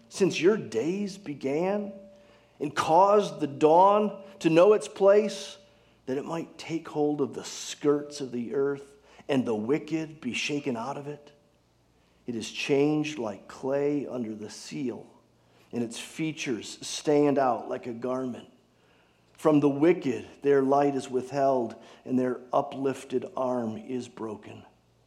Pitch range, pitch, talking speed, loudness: 125-160 Hz, 140 Hz, 145 wpm, -27 LUFS